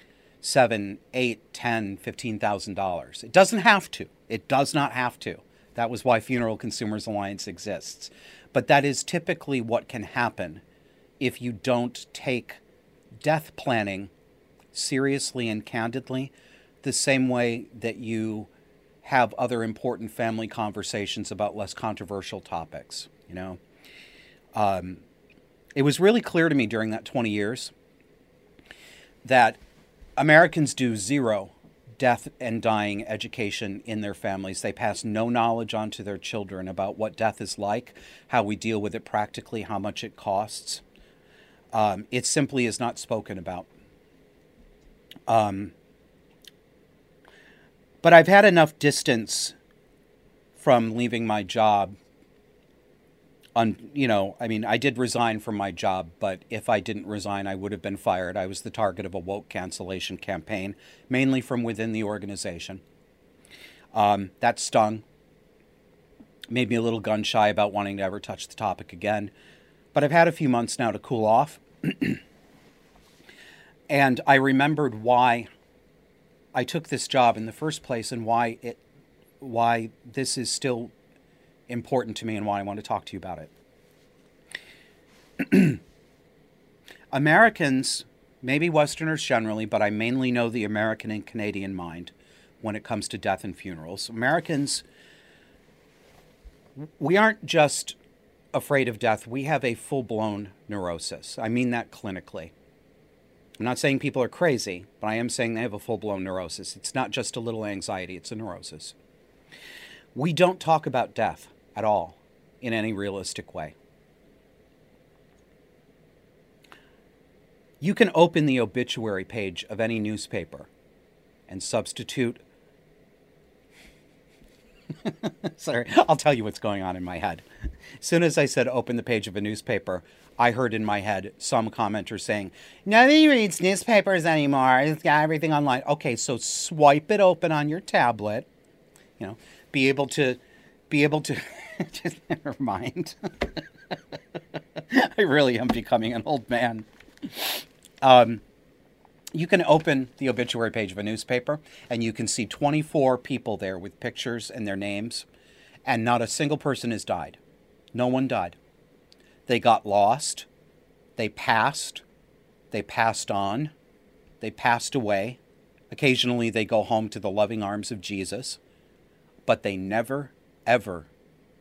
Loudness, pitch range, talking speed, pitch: -25 LUFS, 105-135 Hz, 145 wpm, 115 Hz